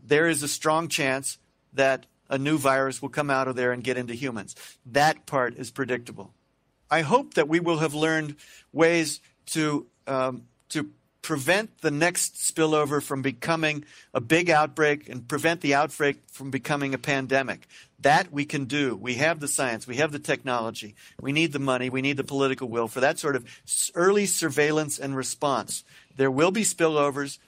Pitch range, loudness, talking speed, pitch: 130-155 Hz, -25 LUFS, 180 wpm, 145 Hz